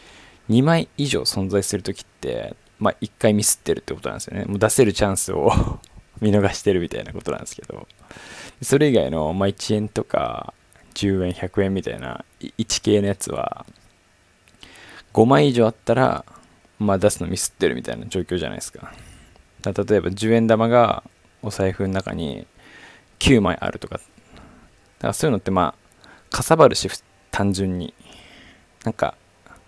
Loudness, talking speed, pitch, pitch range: -21 LUFS, 305 characters per minute, 100 Hz, 95-110 Hz